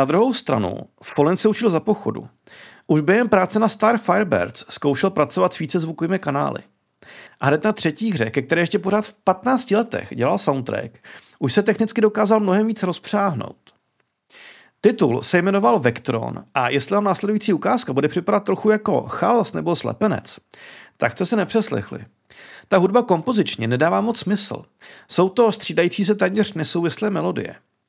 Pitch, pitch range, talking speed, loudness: 200 Hz, 170-215 Hz, 160 wpm, -20 LUFS